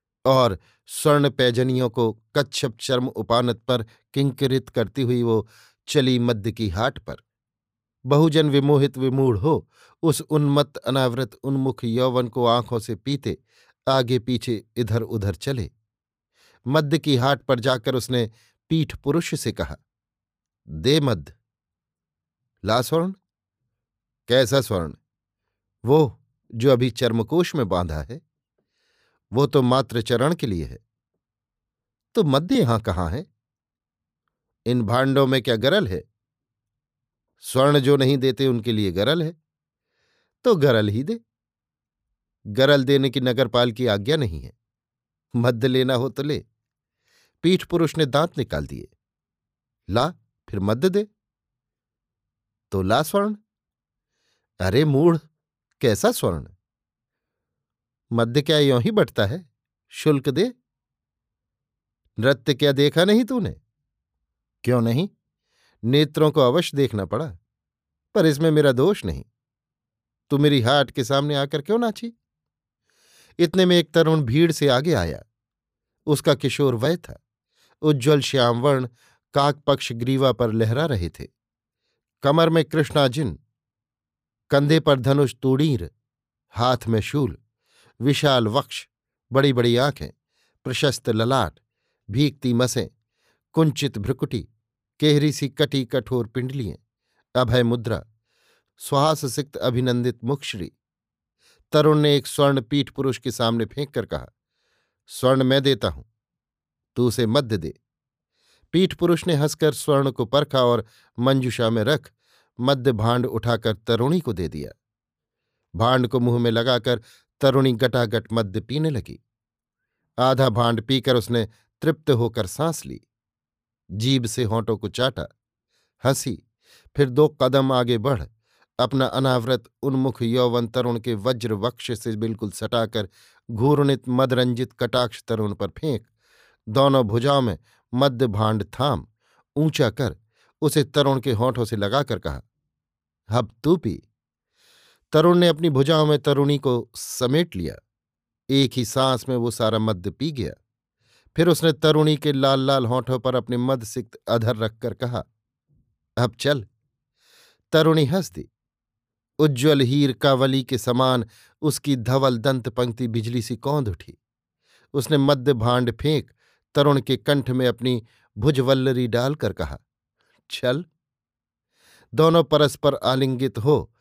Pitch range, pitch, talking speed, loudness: 115-145 Hz, 130 Hz, 130 wpm, -21 LUFS